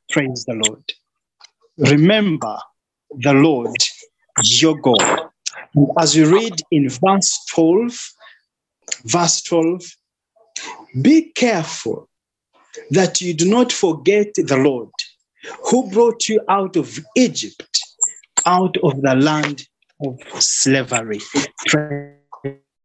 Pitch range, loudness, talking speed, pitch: 145-220 Hz, -16 LUFS, 100 wpm, 165 Hz